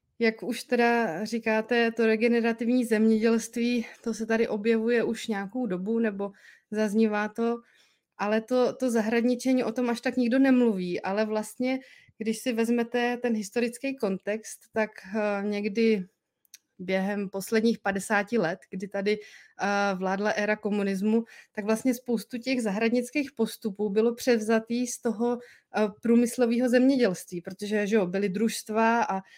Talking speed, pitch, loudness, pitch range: 130 wpm, 225 Hz, -27 LUFS, 210-240 Hz